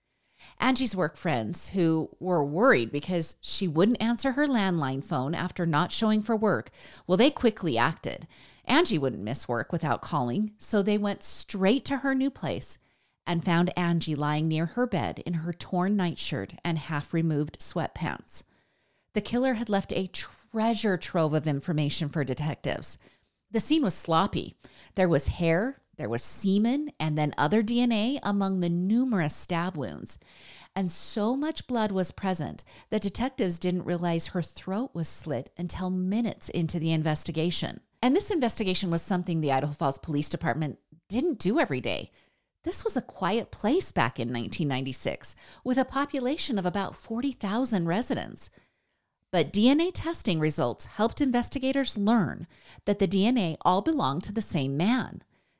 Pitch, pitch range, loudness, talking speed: 180 Hz, 160-225 Hz, -28 LUFS, 155 wpm